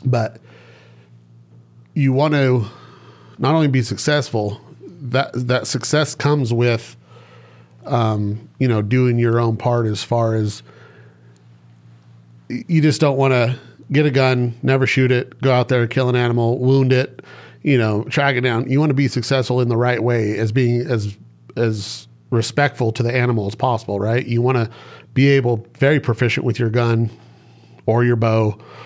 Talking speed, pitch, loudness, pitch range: 165 wpm, 120 Hz, -18 LUFS, 110-130 Hz